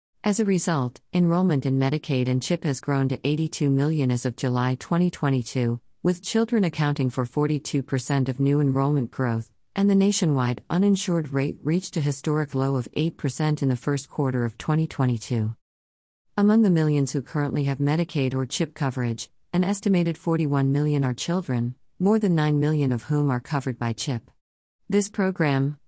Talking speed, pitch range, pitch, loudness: 165 wpm, 130-165 Hz, 145 Hz, -24 LUFS